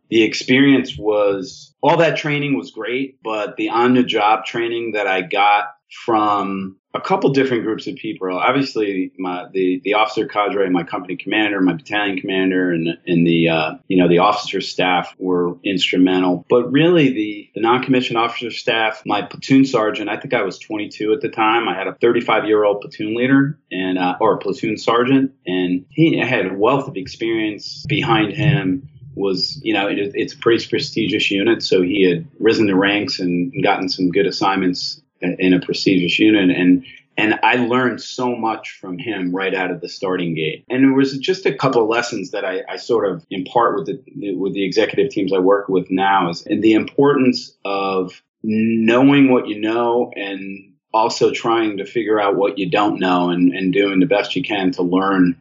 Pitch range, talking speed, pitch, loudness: 95-130 Hz, 185 wpm, 105 Hz, -17 LUFS